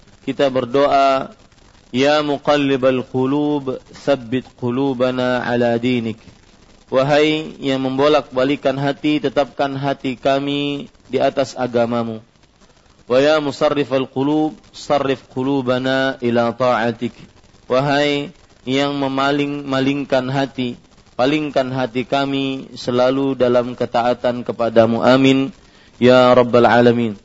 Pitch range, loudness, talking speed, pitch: 120-140 Hz, -17 LUFS, 90 wpm, 130 Hz